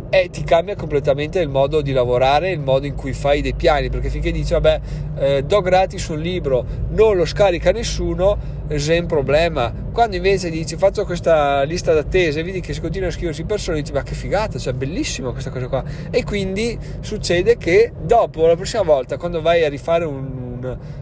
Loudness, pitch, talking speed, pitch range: -19 LUFS, 155 Hz, 195 wpm, 140-180 Hz